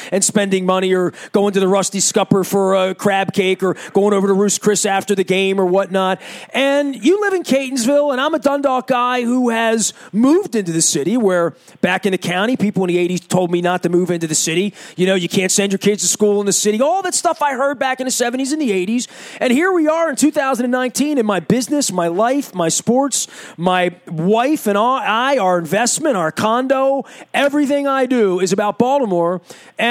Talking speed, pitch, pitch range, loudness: 220 wpm, 205 Hz, 185-265 Hz, -16 LUFS